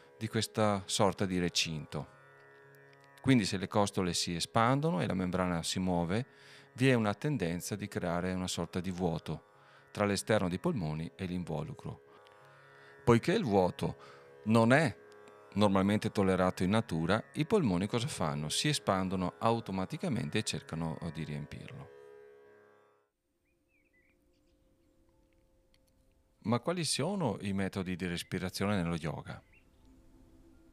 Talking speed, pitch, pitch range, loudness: 120 wpm, 90 Hz, 80-105 Hz, -33 LUFS